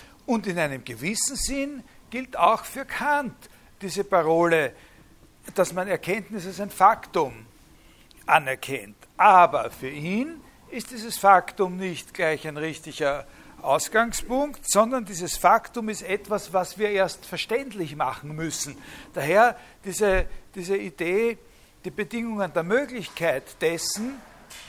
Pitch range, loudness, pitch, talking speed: 165-230 Hz, -24 LUFS, 195 Hz, 120 wpm